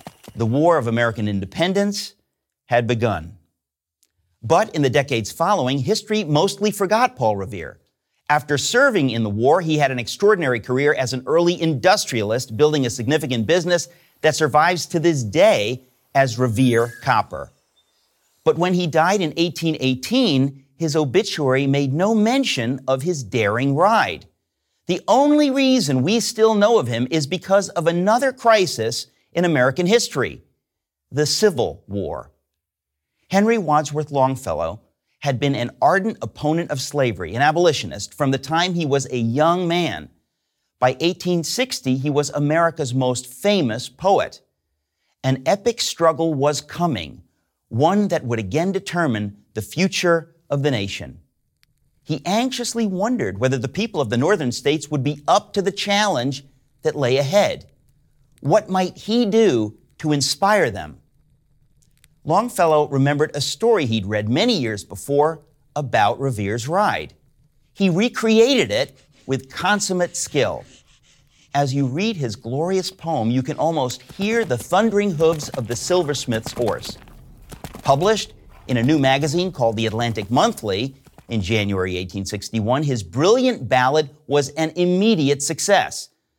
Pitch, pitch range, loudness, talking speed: 145 Hz, 120-180 Hz, -20 LUFS, 140 wpm